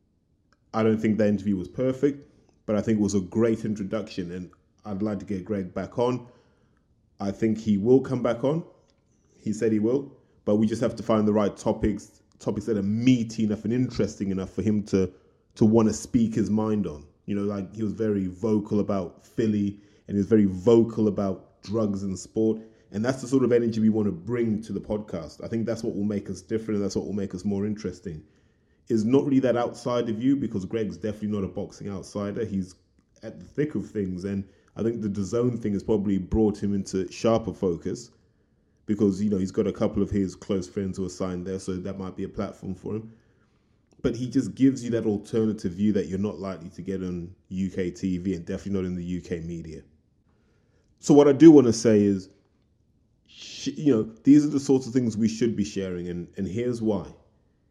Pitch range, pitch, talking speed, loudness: 95-115 Hz, 105 Hz, 220 wpm, -26 LUFS